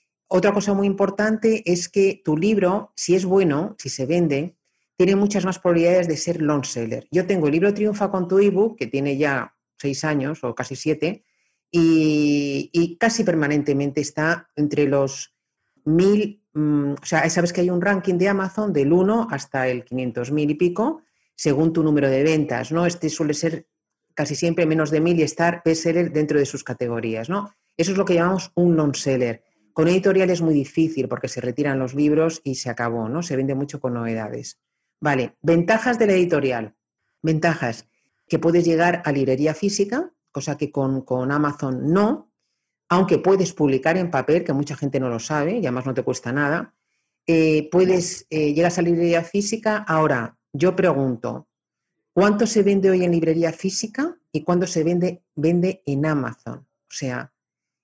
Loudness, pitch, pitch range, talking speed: -21 LUFS, 160 Hz, 140-180 Hz, 180 wpm